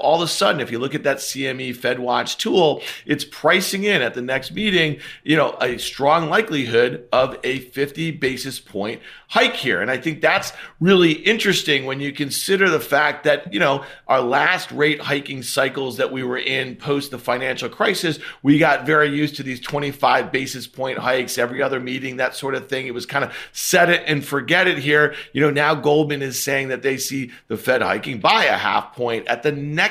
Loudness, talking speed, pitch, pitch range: -19 LUFS, 210 wpm, 140 Hz, 130-155 Hz